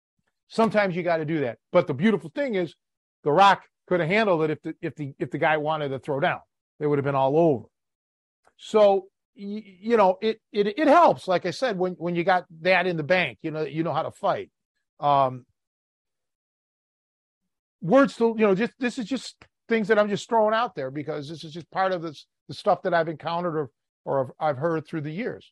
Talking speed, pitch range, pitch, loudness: 225 wpm, 155-205 Hz, 175 Hz, -24 LUFS